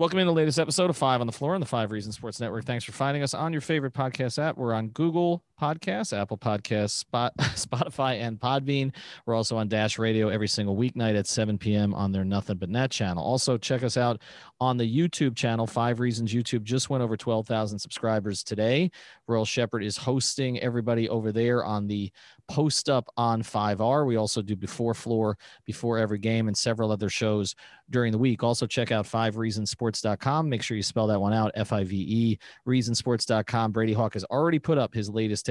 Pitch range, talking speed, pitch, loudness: 110-130 Hz, 210 wpm, 115 Hz, -27 LUFS